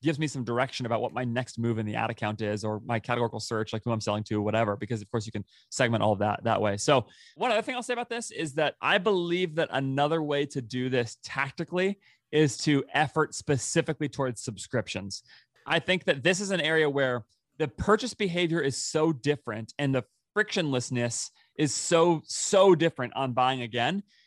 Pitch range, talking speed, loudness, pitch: 115-165 Hz, 210 wpm, -28 LUFS, 135 Hz